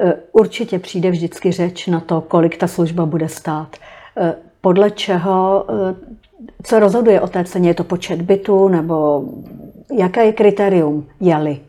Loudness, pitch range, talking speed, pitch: -16 LUFS, 170-205 Hz, 140 wpm, 185 Hz